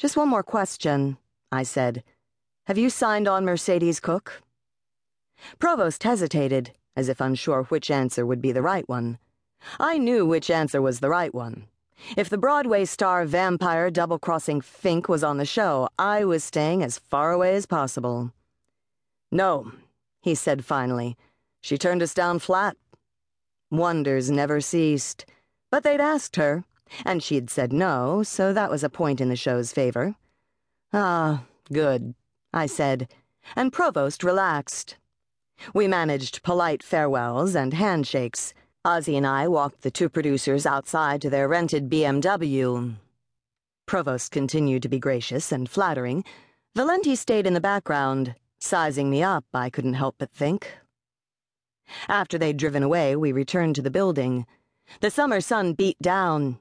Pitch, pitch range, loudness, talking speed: 150 Hz, 130-185 Hz, -24 LUFS, 150 wpm